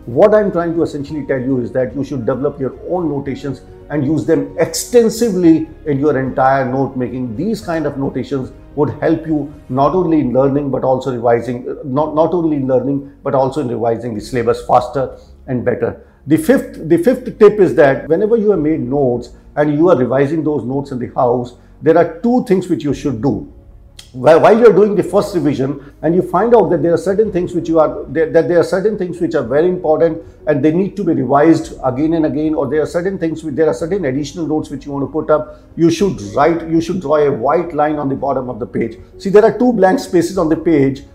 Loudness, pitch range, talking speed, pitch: -15 LUFS, 135-170 Hz, 230 wpm, 150 Hz